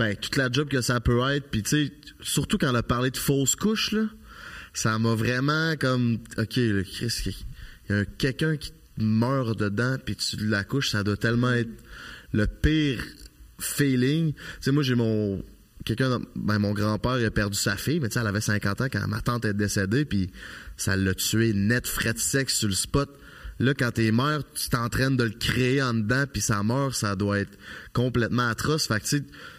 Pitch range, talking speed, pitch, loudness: 105-135 Hz, 215 wpm, 120 Hz, -26 LUFS